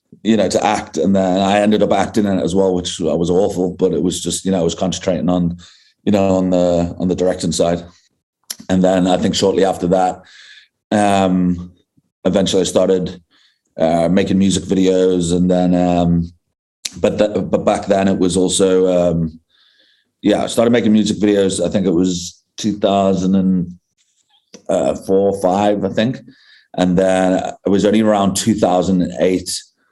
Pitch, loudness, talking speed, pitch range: 95 Hz, -16 LUFS, 170 wpm, 90-95 Hz